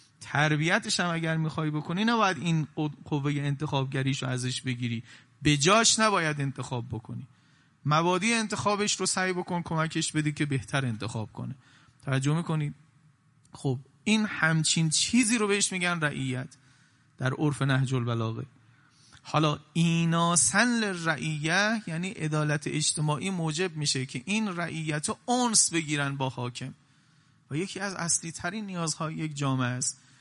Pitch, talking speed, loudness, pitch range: 155 Hz, 135 wpm, -27 LUFS, 135-175 Hz